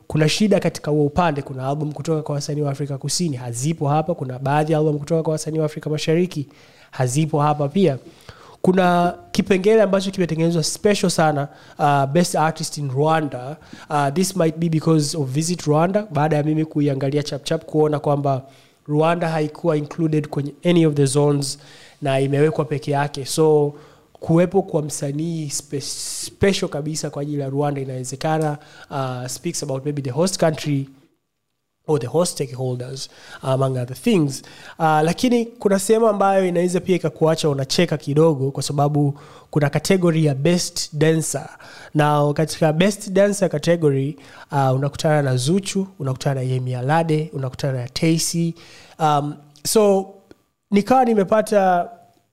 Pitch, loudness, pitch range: 155 Hz, -20 LUFS, 145-170 Hz